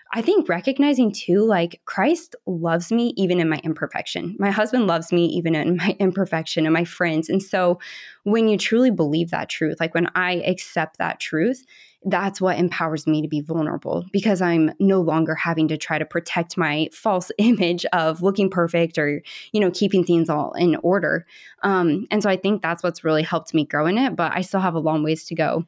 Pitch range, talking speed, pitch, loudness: 160-195 Hz, 210 wpm, 175 Hz, -21 LUFS